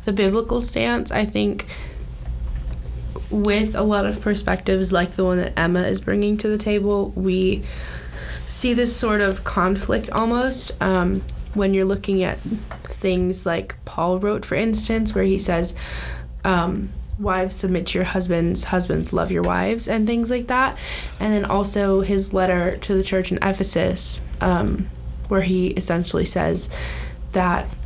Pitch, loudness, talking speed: 185 Hz, -21 LUFS, 155 wpm